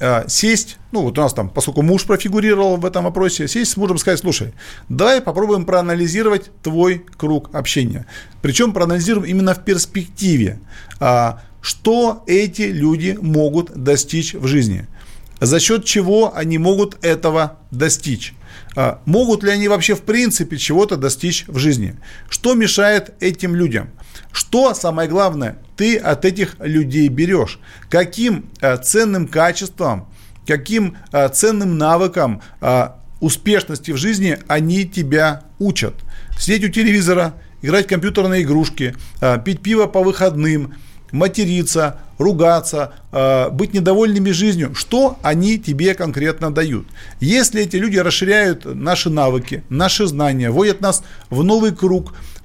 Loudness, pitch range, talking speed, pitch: -16 LUFS, 145-200 Hz, 125 wpm, 175 Hz